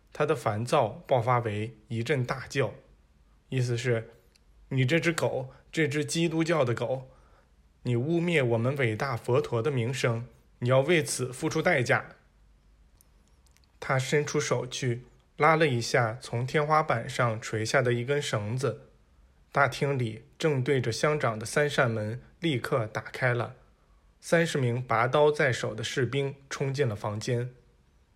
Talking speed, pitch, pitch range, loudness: 210 characters per minute, 125 Hz, 110-145 Hz, -28 LUFS